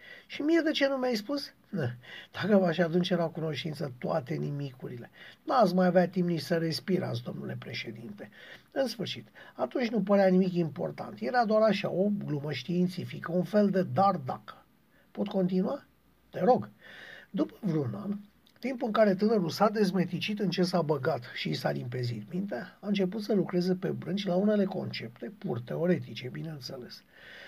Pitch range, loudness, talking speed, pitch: 170-210 Hz, -30 LUFS, 165 wpm, 185 Hz